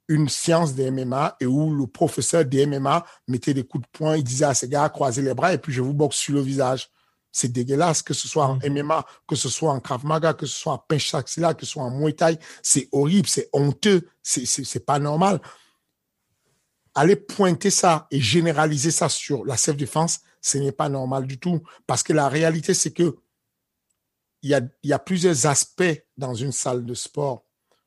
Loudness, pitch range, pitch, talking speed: -22 LUFS, 135-165 Hz, 145 Hz, 215 wpm